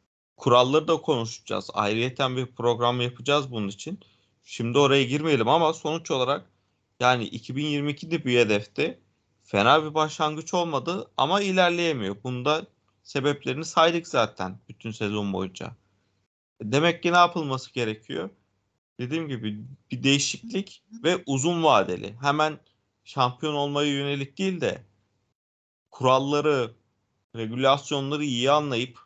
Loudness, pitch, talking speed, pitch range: -25 LUFS, 135 Hz, 110 wpm, 115-155 Hz